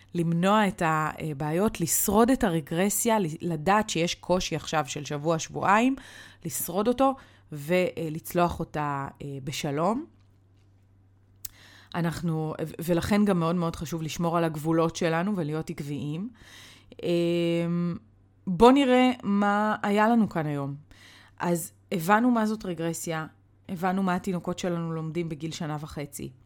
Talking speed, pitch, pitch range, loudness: 115 wpm, 170 Hz, 150-190 Hz, -26 LUFS